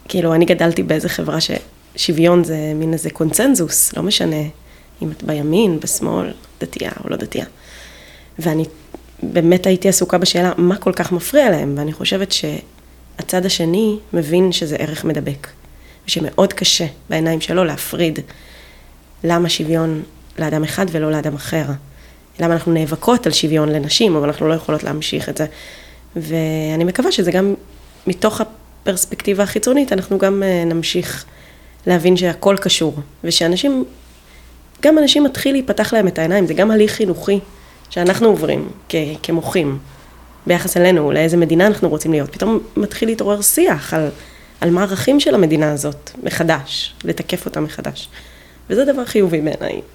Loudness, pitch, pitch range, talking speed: -16 LUFS, 165 Hz, 150-190 Hz, 140 wpm